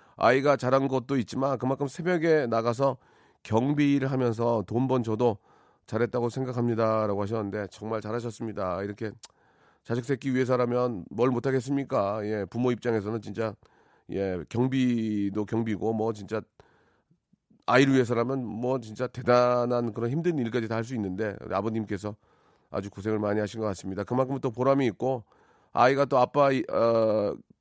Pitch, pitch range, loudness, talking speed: 120 Hz, 110-130 Hz, -27 LUFS, 335 characters per minute